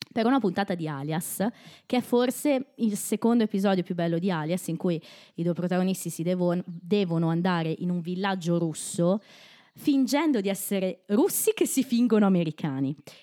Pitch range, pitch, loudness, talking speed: 170-225 Hz, 190 Hz, -27 LUFS, 165 wpm